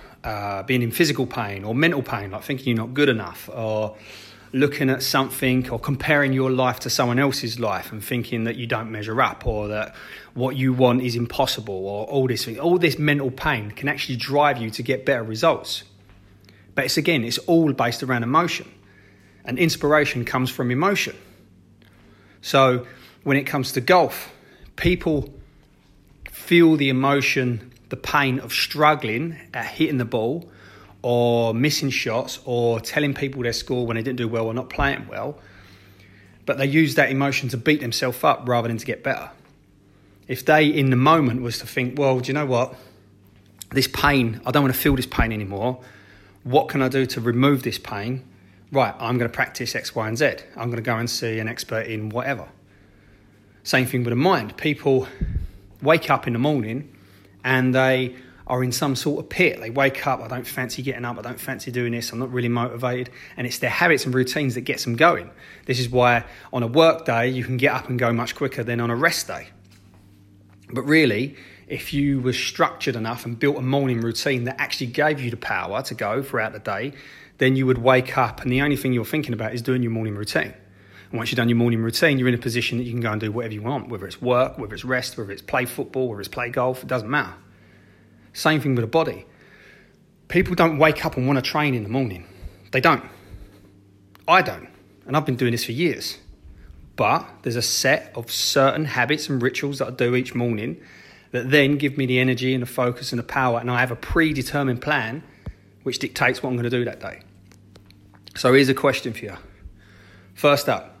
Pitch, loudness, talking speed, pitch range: 125 Hz, -22 LUFS, 210 wpm, 110-135 Hz